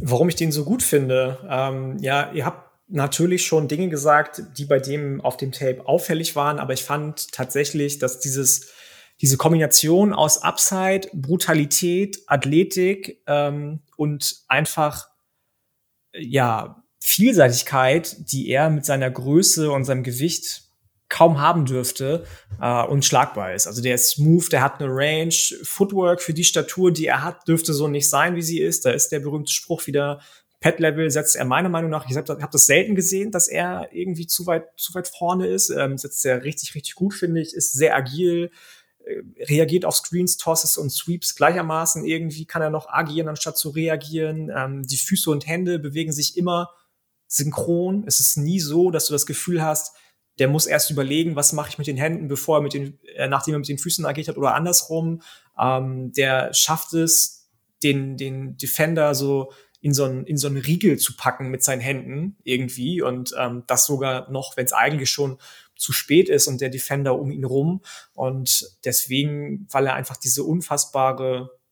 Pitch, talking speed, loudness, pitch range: 150 Hz, 180 wpm, -20 LUFS, 135-165 Hz